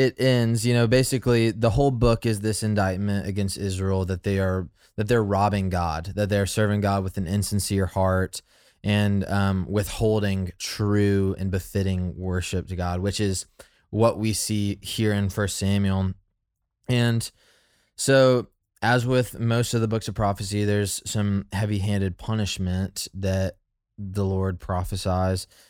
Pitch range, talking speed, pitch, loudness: 95-110 Hz, 150 wpm, 100 Hz, -24 LUFS